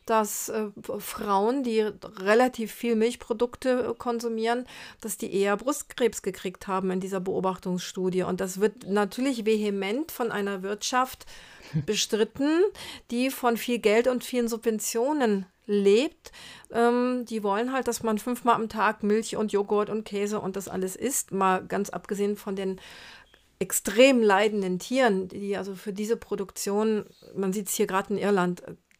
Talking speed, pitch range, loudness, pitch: 150 wpm, 195-235 Hz, -27 LUFS, 215 Hz